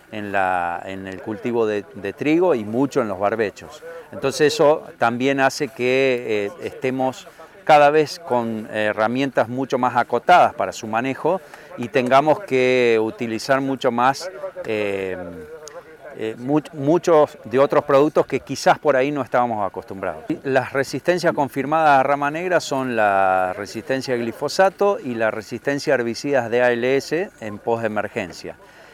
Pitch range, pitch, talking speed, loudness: 110-145 Hz, 130 Hz, 150 wpm, -20 LUFS